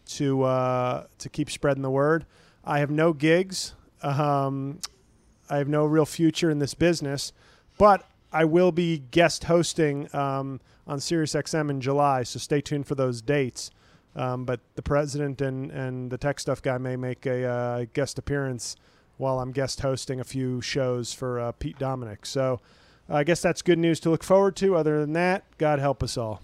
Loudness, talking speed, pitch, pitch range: -26 LUFS, 190 wpm, 140 Hz, 130-155 Hz